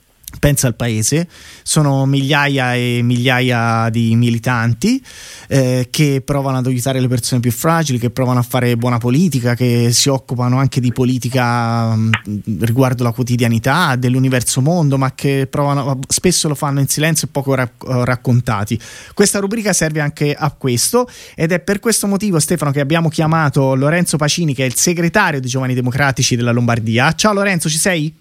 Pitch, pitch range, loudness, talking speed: 130 Hz, 125-155 Hz, -15 LUFS, 165 wpm